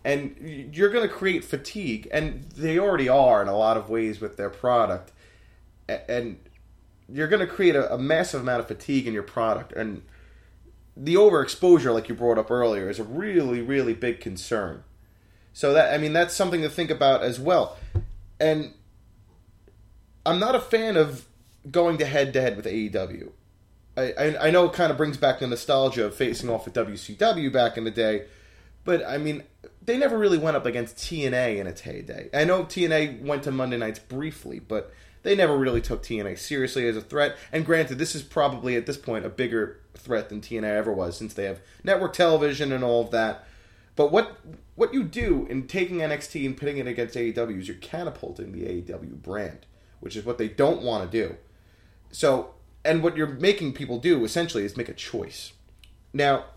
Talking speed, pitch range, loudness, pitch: 195 wpm, 105-155 Hz, -25 LUFS, 125 Hz